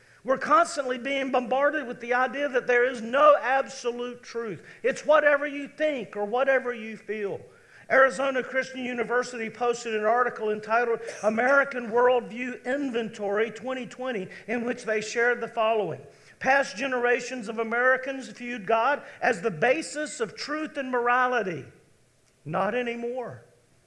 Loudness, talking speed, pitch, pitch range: -26 LUFS, 135 wpm, 245 Hz, 230-265 Hz